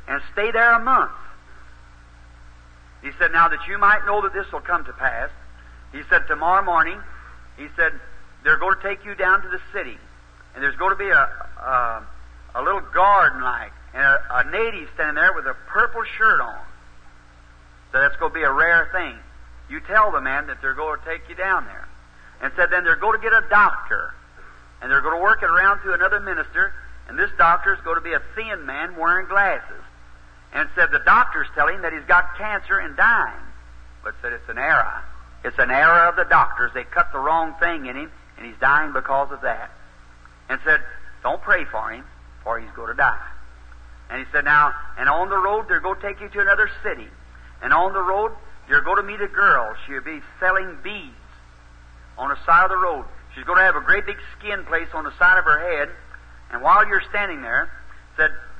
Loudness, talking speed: -19 LUFS, 215 wpm